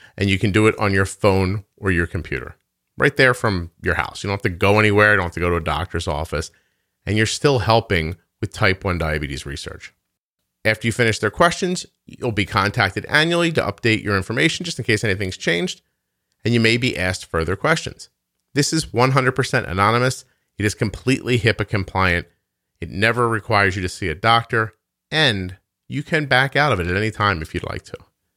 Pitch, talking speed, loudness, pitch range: 105 Hz, 205 wpm, -19 LUFS, 90-120 Hz